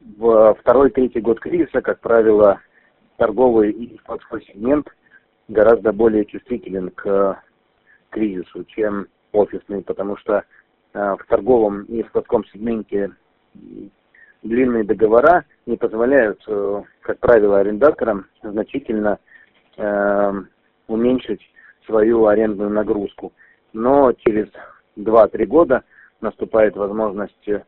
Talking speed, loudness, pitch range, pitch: 90 wpm, -18 LUFS, 100-115 Hz, 105 Hz